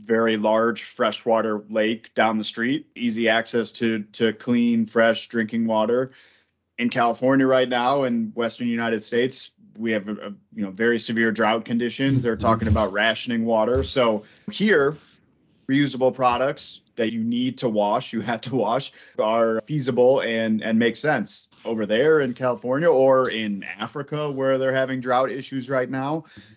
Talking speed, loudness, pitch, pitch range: 160 wpm, -22 LUFS, 115 Hz, 110-130 Hz